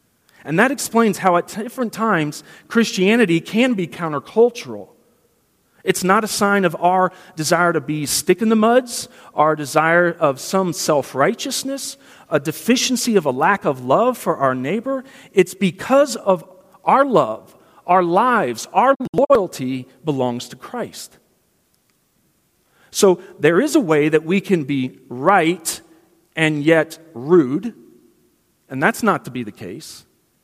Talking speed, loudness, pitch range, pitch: 140 wpm, -18 LUFS, 155-230 Hz, 185 Hz